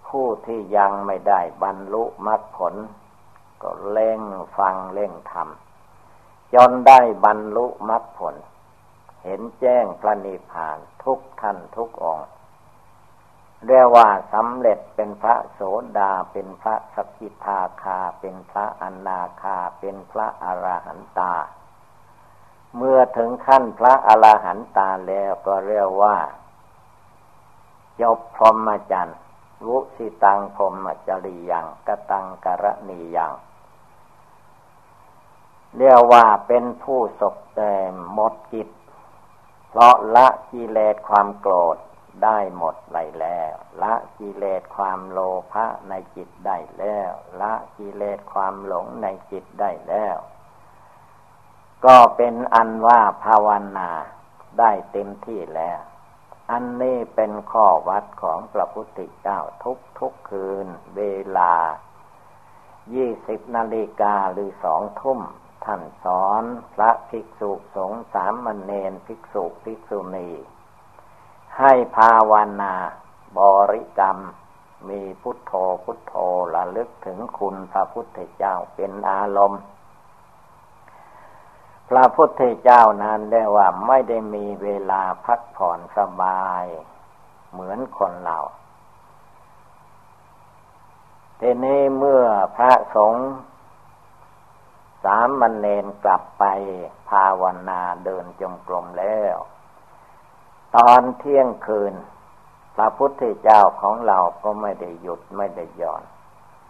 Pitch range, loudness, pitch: 95-115 Hz, -19 LUFS, 105 Hz